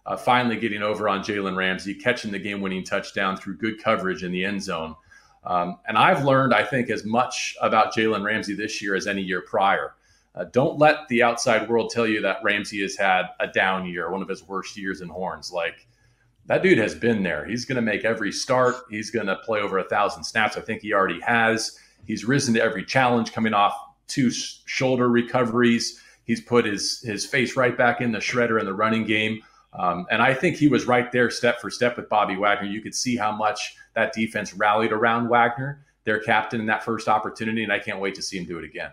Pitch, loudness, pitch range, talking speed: 110 Hz, -23 LUFS, 100-120 Hz, 225 wpm